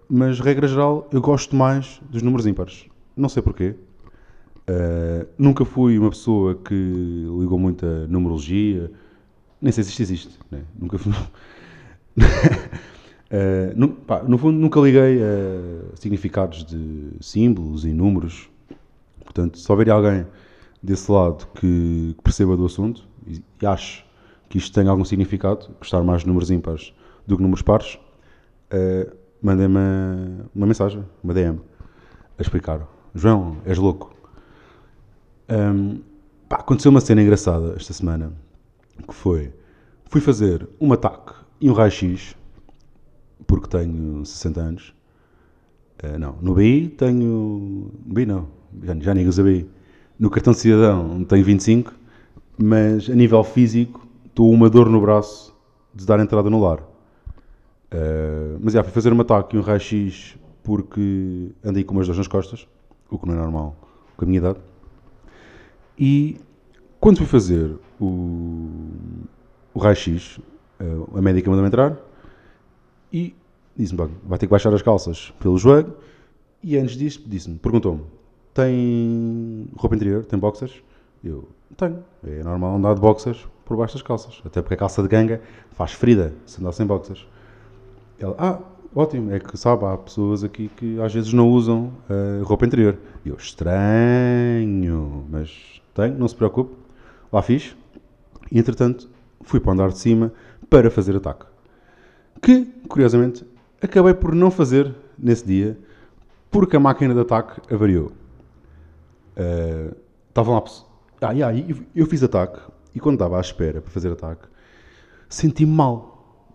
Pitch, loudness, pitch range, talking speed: 105 Hz, -19 LUFS, 90-120 Hz, 150 wpm